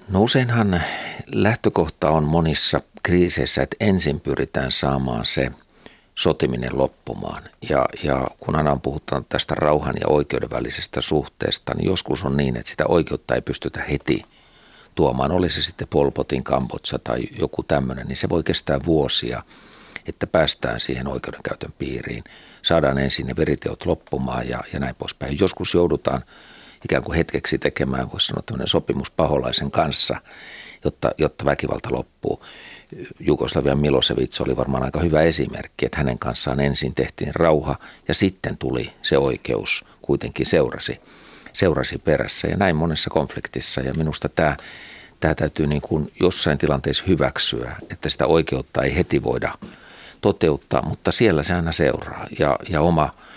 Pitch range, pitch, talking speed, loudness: 65-85 Hz, 70 Hz, 145 wpm, -21 LUFS